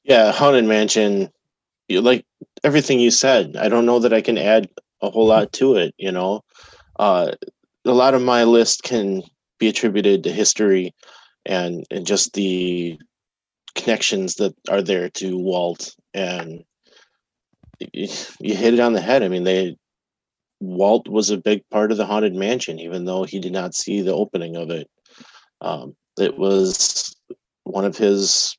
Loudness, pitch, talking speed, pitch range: -18 LUFS, 100 Hz, 160 wpm, 95-115 Hz